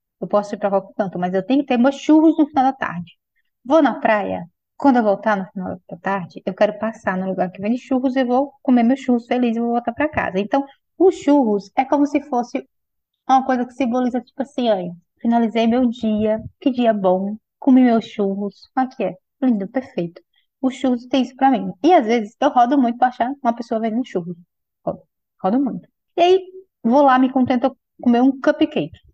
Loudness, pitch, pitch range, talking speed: -19 LUFS, 245 Hz, 210-270 Hz, 215 wpm